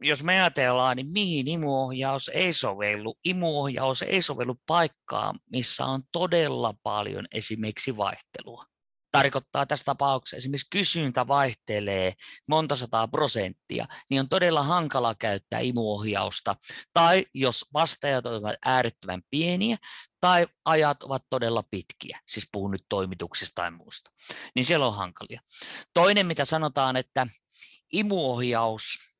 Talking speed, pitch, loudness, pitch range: 125 wpm, 135 Hz, -26 LUFS, 115-160 Hz